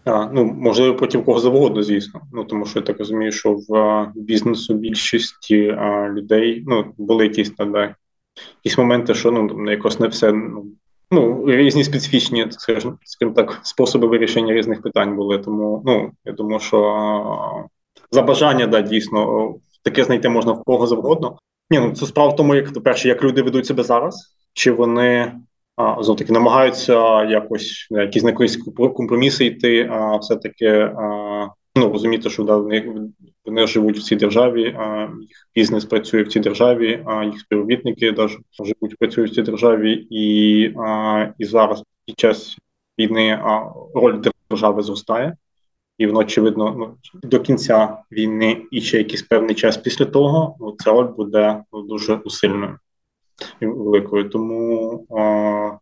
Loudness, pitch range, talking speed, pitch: -17 LUFS, 105-120 Hz, 155 wpm, 110 Hz